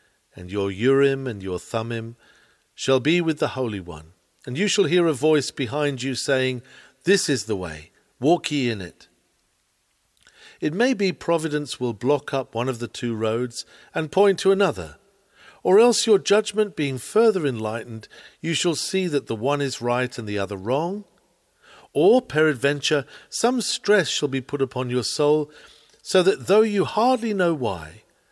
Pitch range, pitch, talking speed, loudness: 120-185 Hz, 145 Hz, 170 wpm, -22 LUFS